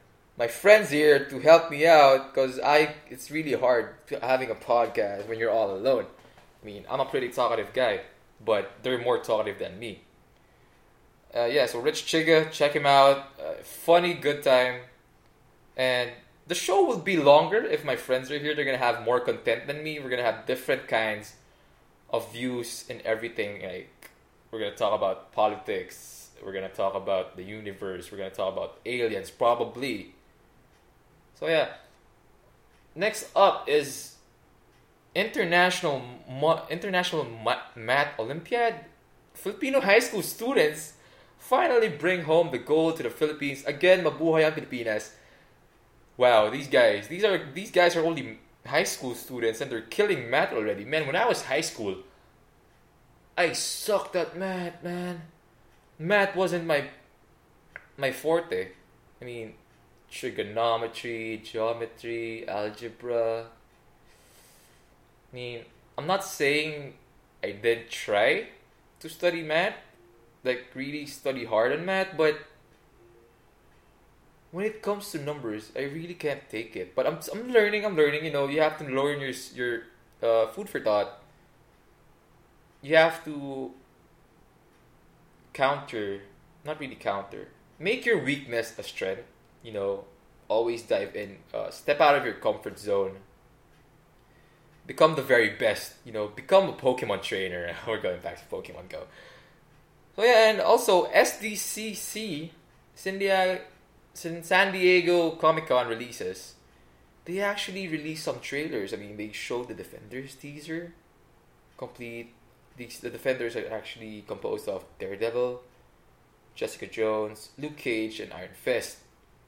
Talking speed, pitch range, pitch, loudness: 140 wpm, 115-170 Hz, 140 Hz, -26 LUFS